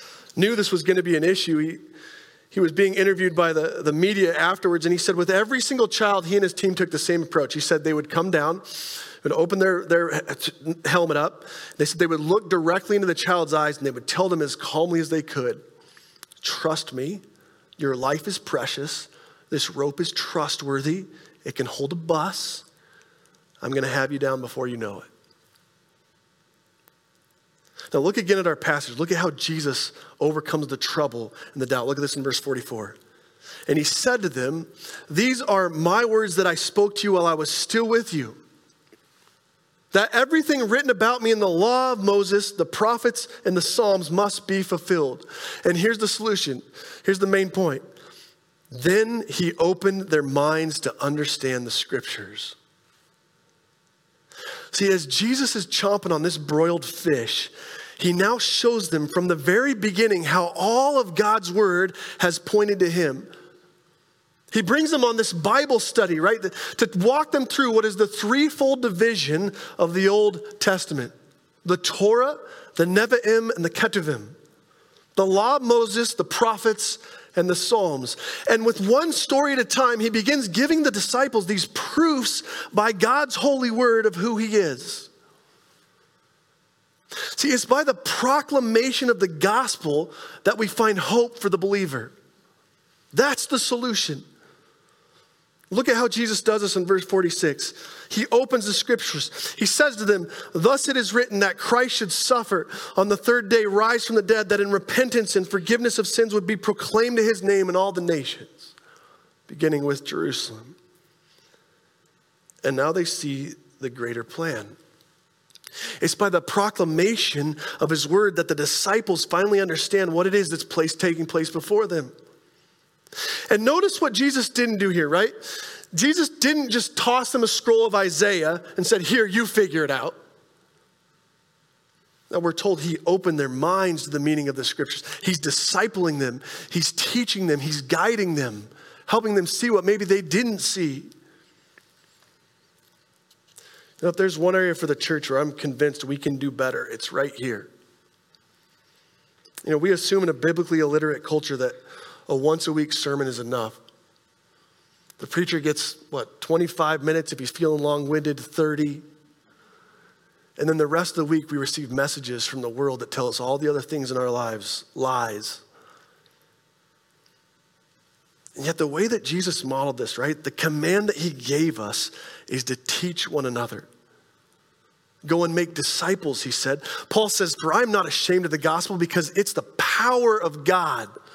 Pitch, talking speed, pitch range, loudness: 180 Hz, 170 wpm, 155-220 Hz, -22 LUFS